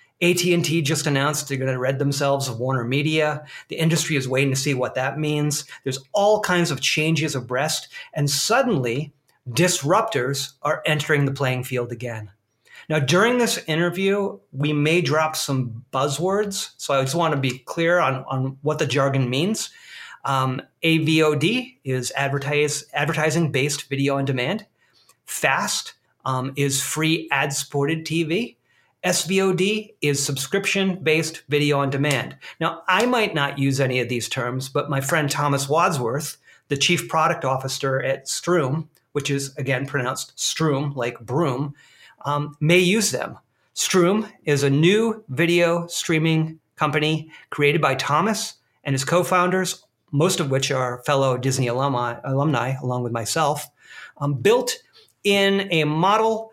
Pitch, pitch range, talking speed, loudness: 145 Hz, 135-170 Hz, 145 wpm, -22 LUFS